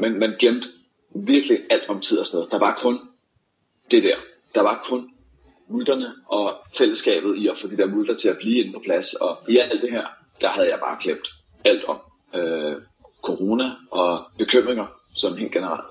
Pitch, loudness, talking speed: 250 Hz, -22 LUFS, 190 wpm